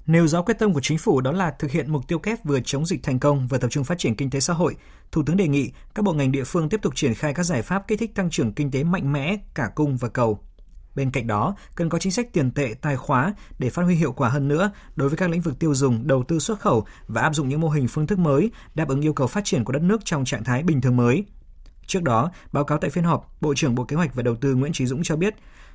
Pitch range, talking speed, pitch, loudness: 135-175 Hz, 300 wpm, 150 Hz, -23 LUFS